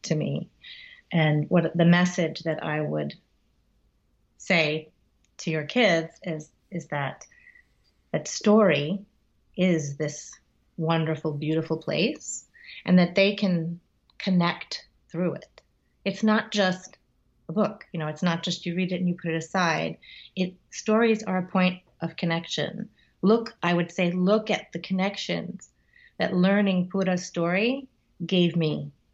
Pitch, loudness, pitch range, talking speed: 180 Hz, -26 LUFS, 160-195 Hz, 140 wpm